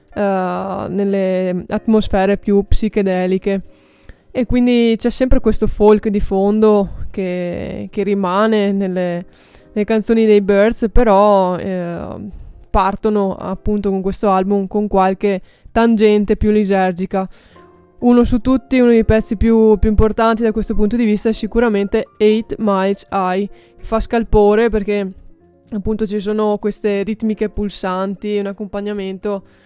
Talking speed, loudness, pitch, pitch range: 125 wpm, -16 LUFS, 210 Hz, 195-220 Hz